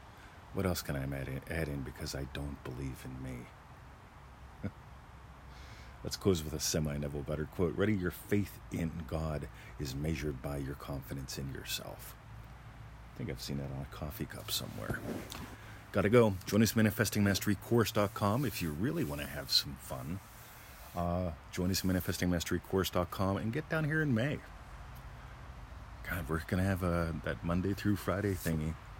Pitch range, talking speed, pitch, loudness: 75-105 Hz, 165 wpm, 90 Hz, -35 LUFS